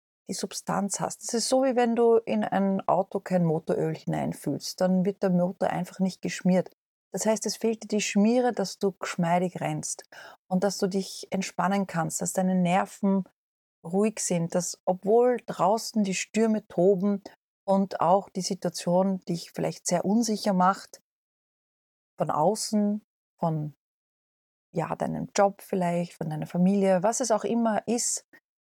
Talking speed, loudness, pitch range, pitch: 155 wpm, -27 LUFS, 180-210 Hz, 195 Hz